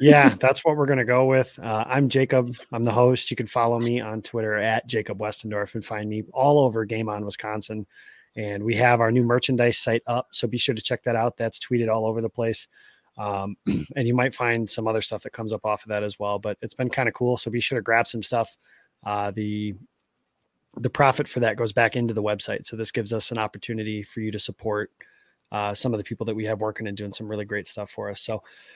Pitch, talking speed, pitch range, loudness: 115 Hz, 250 wpm, 105-125 Hz, -24 LUFS